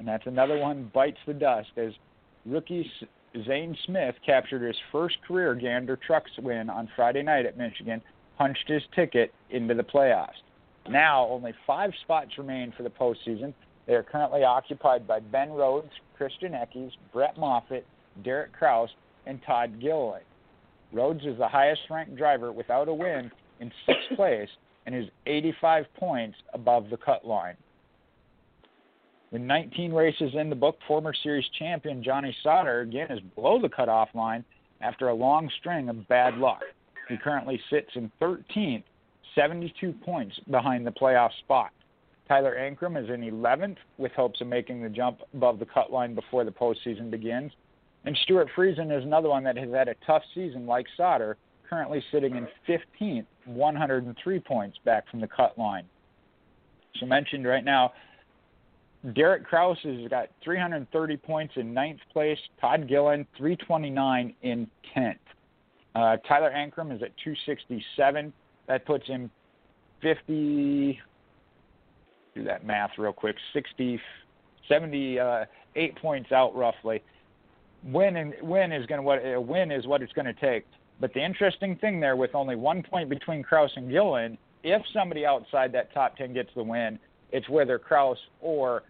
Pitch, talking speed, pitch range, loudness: 135 Hz, 155 wpm, 120-155 Hz, -27 LUFS